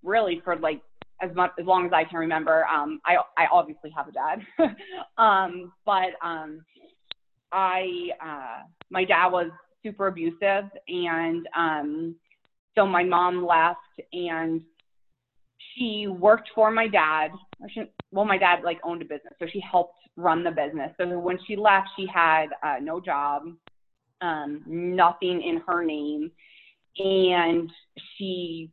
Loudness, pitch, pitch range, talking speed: -25 LUFS, 175 Hz, 165-190 Hz, 145 wpm